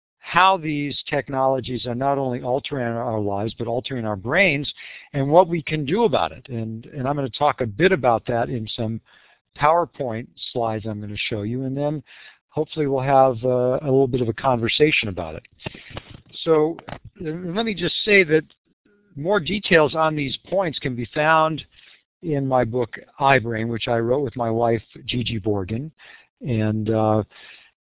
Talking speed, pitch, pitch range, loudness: 175 wpm, 130 Hz, 115-155 Hz, -21 LUFS